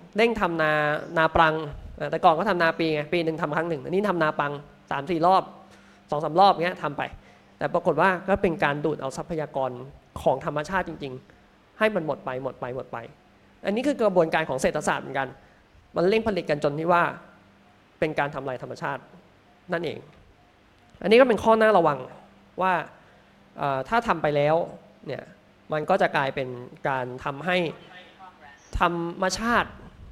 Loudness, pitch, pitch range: -25 LUFS, 160 Hz, 150-185 Hz